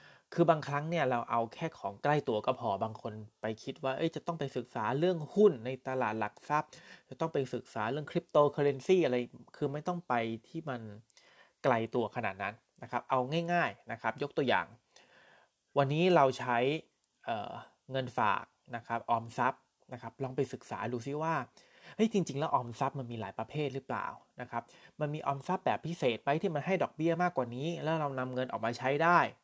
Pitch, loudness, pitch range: 135 Hz, -33 LUFS, 120-165 Hz